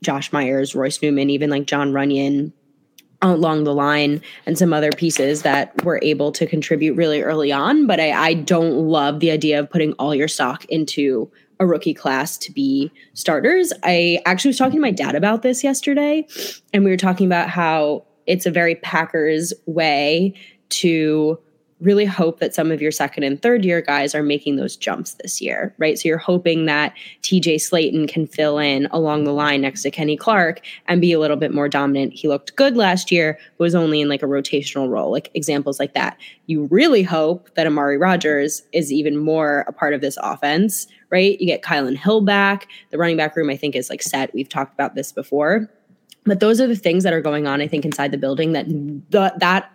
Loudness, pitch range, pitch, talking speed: -18 LUFS, 145-180 Hz, 160 Hz, 210 wpm